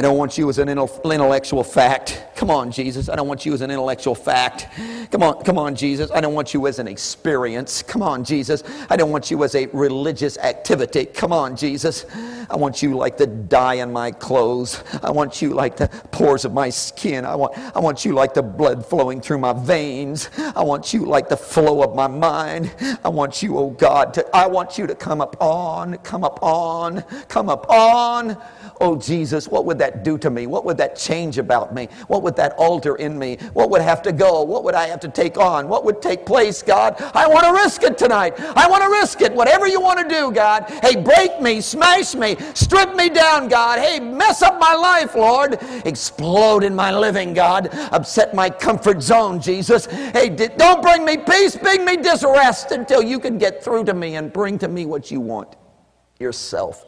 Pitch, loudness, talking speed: 180 Hz, -17 LUFS, 215 wpm